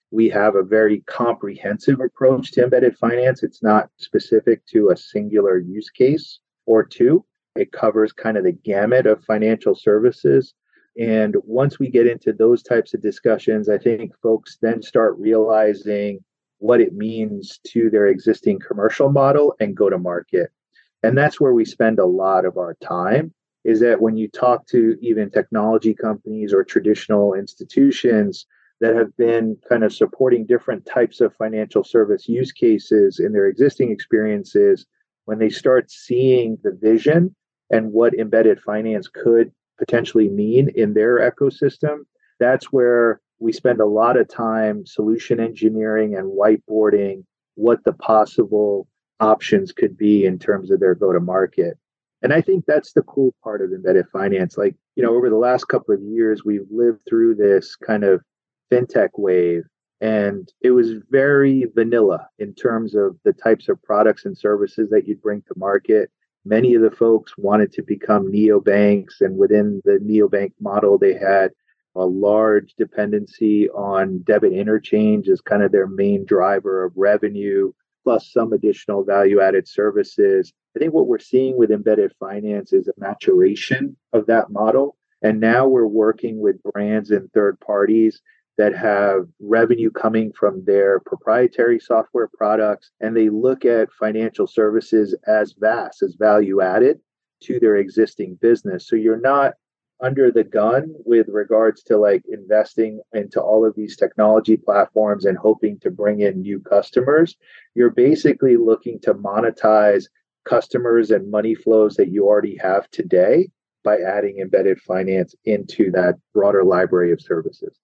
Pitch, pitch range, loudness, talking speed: 110 Hz, 105-140 Hz, -18 LUFS, 160 wpm